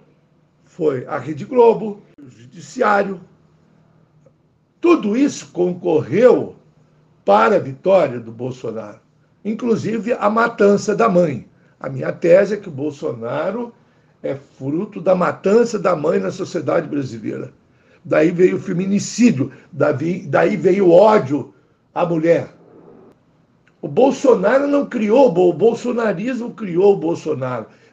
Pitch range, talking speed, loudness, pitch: 155-220 Hz, 115 wpm, -17 LUFS, 185 Hz